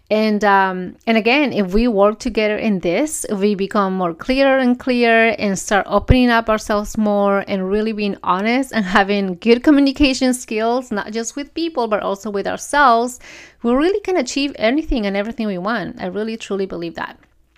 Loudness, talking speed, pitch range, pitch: -17 LUFS, 180 wpm, 200-250 Hz, 220 Hz